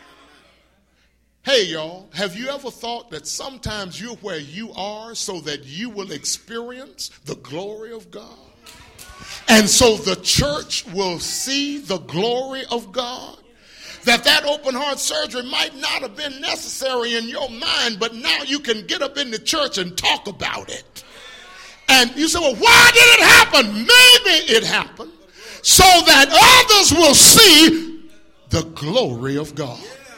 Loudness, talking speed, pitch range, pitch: -13 LUFS, 155 wpm, 200-295 Hz, 240 Hz